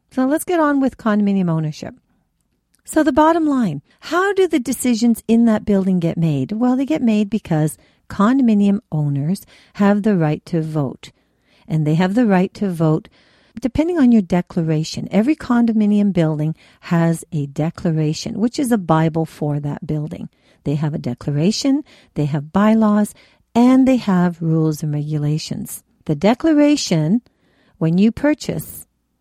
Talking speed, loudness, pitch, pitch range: 150 wpm, -18 LUFS, 200 Hz, 160-240 Hz